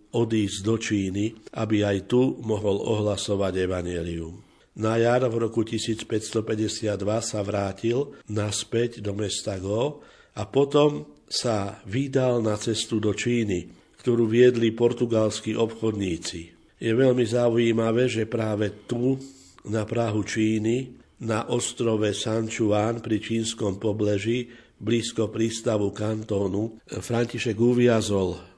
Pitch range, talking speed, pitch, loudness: 105-115 Hz, 110 wpm, 110 Hz, -25 LUFS